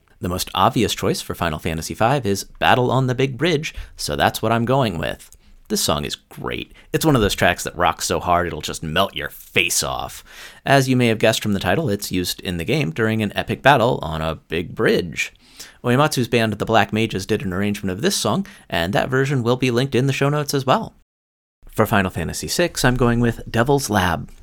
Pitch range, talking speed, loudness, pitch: 90-125 Hz, 225 wpm, -20 LUFS, 110 Hz